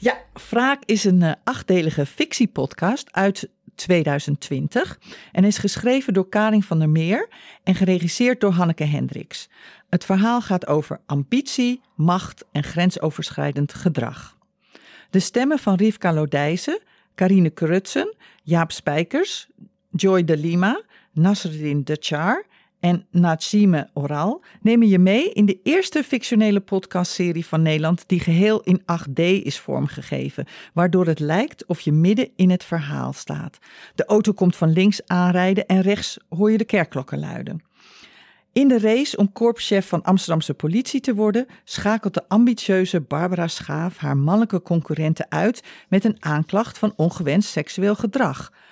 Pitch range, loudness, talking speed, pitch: 165-215 Hz, -20 LUFS, 140 wpm, 185 Hz